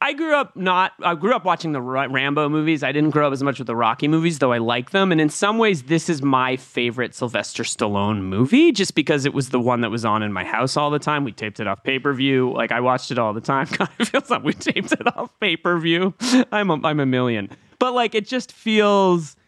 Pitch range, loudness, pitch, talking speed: 125-190 Hz, -20 LUFS, 150 Hz, 260 wpm